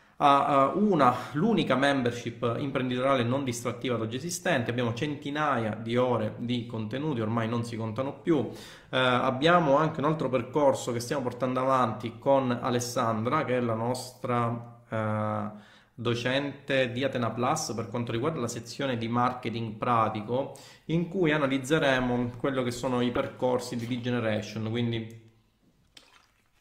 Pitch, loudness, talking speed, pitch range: 125 Hz, -28 LUFS, 135 wpm, 115-135 Hz